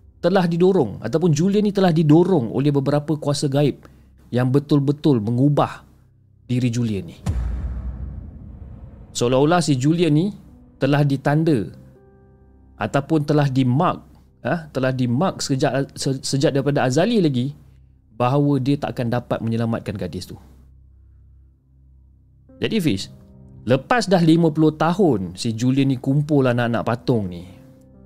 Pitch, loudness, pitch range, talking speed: 130 Hz, -20 LUFS, 90-150 Hz, 120 wpm